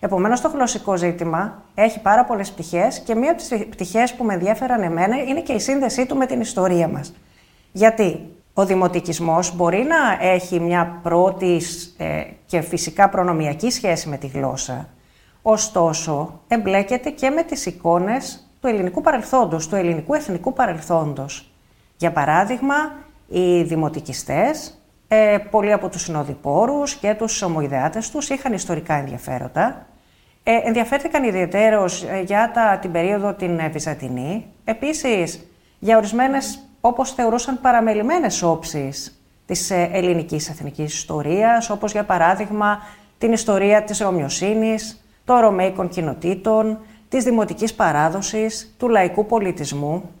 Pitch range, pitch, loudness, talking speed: 170-230 Hz, 195 Hz, -20 LUFS, 130 wpm